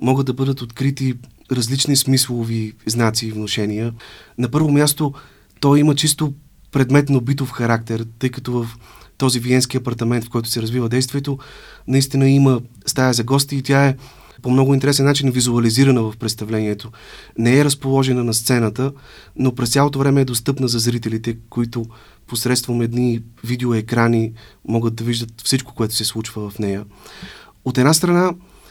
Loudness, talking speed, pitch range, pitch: -18 LUFS, 155 wpm, 115-135 Hz, 125 Hz